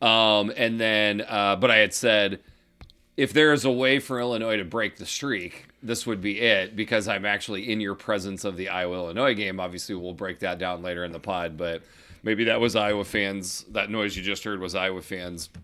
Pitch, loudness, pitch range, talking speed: 100 Hz, -25 LUFS, 90-110 Hz, 220 wpm